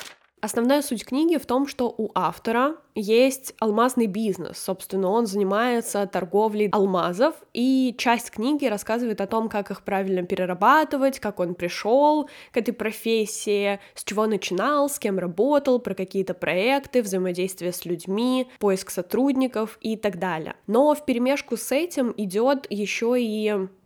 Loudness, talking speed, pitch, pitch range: -24 LUFS, 145 wpm, 220 Hz, 195-255 Hz